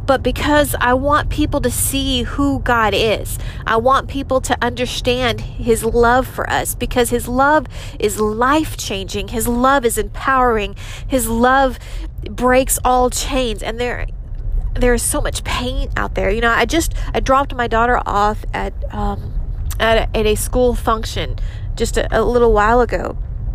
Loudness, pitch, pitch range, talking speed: -17 LUFS, 235 Hz, 210-255 Hz, 170 wpm